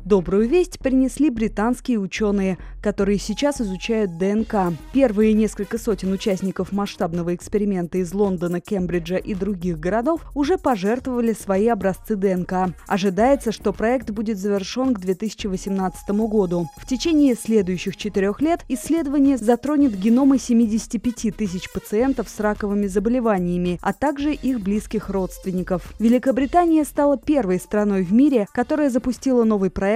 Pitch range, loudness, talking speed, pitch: 195-250 Hz, -21 LUFS, 125 wpm, 215 Hz